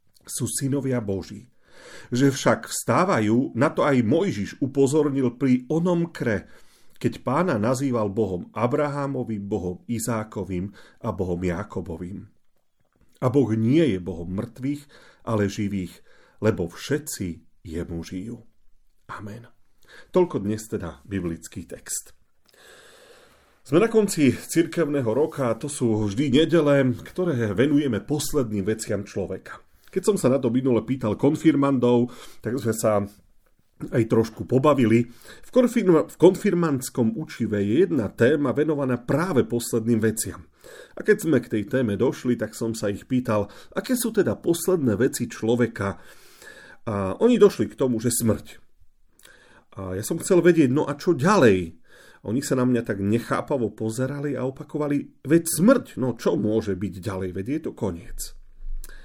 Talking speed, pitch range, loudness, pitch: 140 wpm, 105-145 Hz, -23 LUFS, 120 Hz